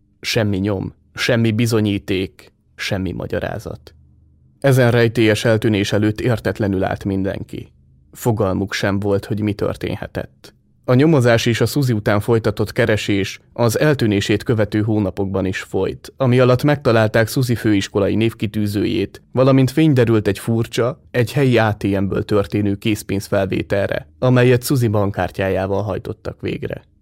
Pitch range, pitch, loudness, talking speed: 100-120 Hz, 110 Hz, -18 LUFS, 120 wpm